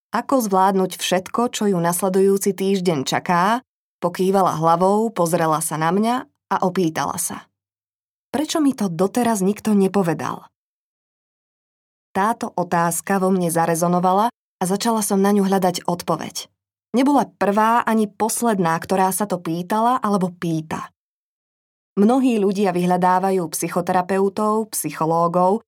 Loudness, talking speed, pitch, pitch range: -20 LUFS, 115 wpm, 190 Hz, 175-215 Hz